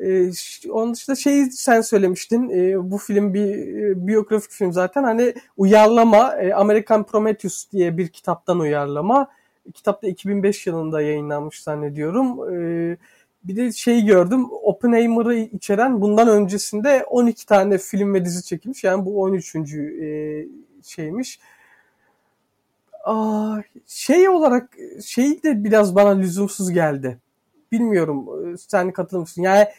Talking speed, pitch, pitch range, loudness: 115 wpm, 205 Hz, 180-230 Hz, -19 LUFS